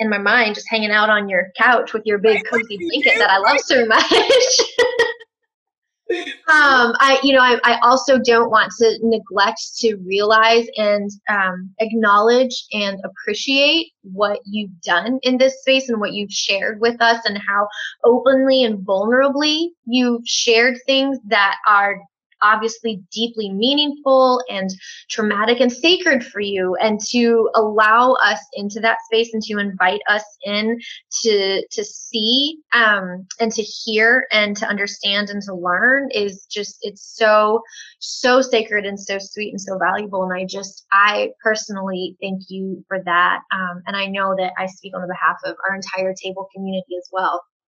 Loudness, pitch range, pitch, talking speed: -17 LUFS, 200-245 Hz, 215 Hz, 165 wpm